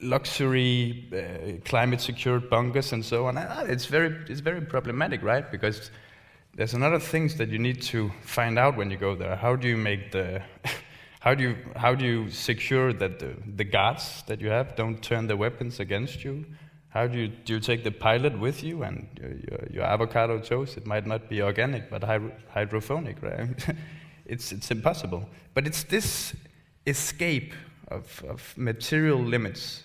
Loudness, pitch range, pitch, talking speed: -28 LUFS, 110-135 Hz, 120 Hz, 185 wpm